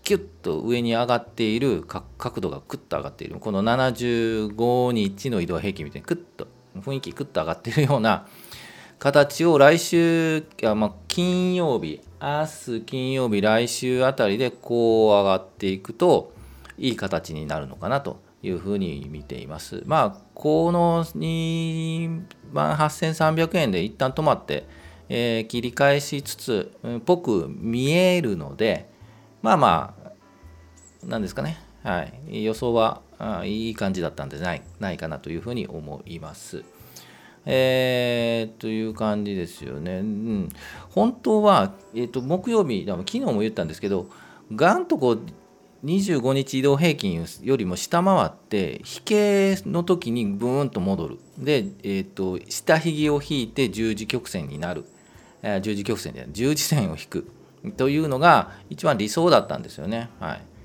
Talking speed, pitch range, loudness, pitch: 285 characters per minute, 105-160 Hz, -23 LUFS, 125 Hz